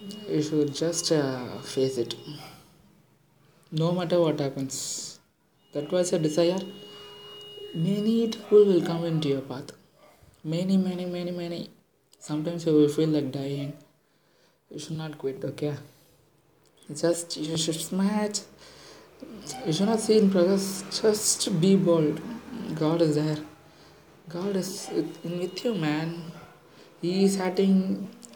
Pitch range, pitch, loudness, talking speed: 155-195 Hz, 170 Hz, -26 LUFS, 125 wpm